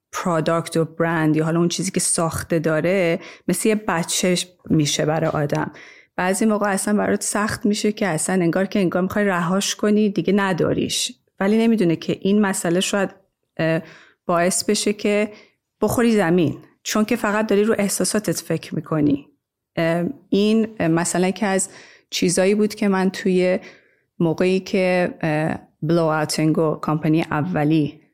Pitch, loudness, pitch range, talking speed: 180 Hz, -20 LUFS, 165-205 Hz, 145 wpm